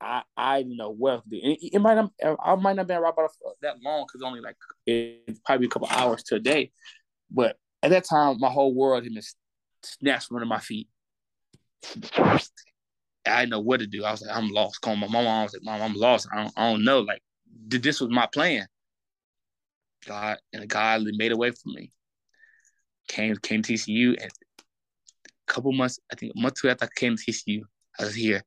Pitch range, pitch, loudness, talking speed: 110-140 Hz, 120 Hz, -25 LUFS, 215 wpm